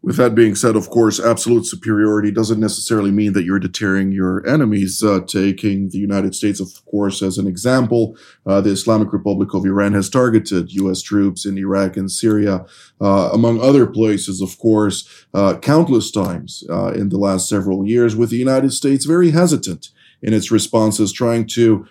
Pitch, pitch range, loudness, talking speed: 105 Hz, 95-115 Hz, -16 LUFS, 180 wpm